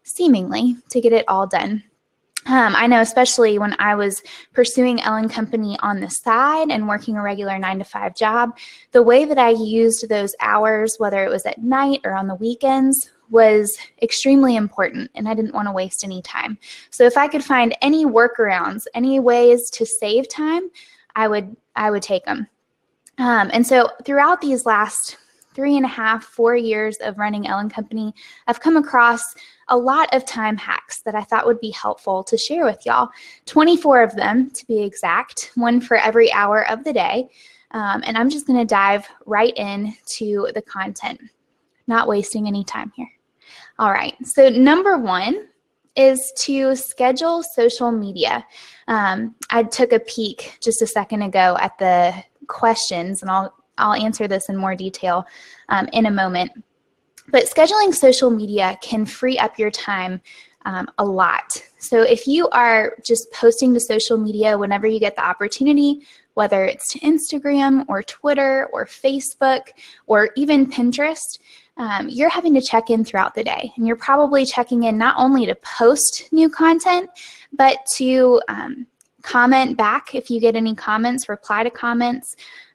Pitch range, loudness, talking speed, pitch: 215-265 Hz, -18 LUFS, 175 wpm, 235 Hz